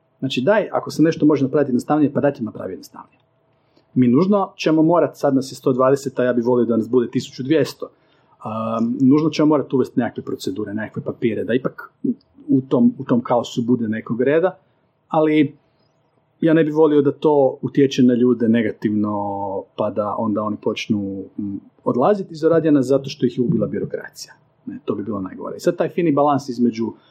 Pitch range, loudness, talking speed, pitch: 120-155 Hz, -19 LUFS, 180 wpm, 135 Hz